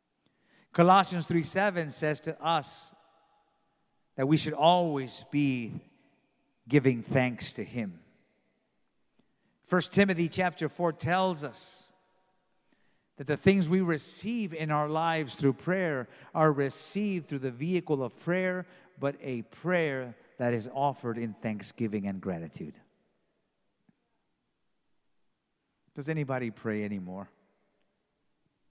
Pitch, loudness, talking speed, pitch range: 155 Hz, -30 LUFS, 110 wpm, 130-180 Hz